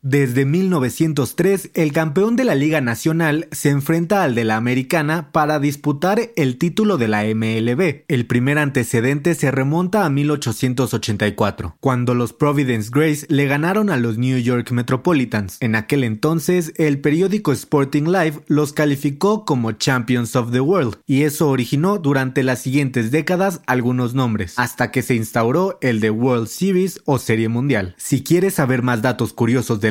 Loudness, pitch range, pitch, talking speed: -18 LUFS, 125-160 Hz, 140 Hz, 160 wpm